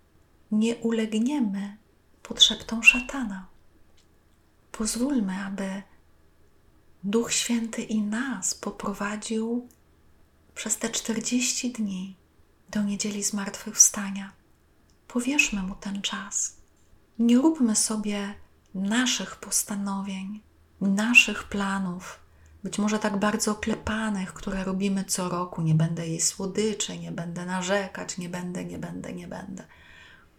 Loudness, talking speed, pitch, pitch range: -25 LUFS, 100 wpm, 200 Hz, 185-225 Hz